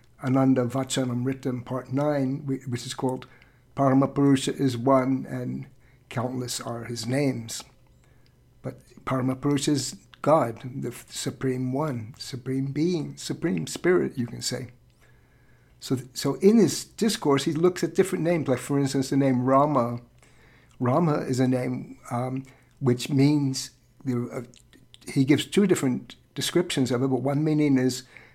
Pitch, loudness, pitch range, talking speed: 130 Hz, -25 LUFS, 125-140 Hz, 135 wpm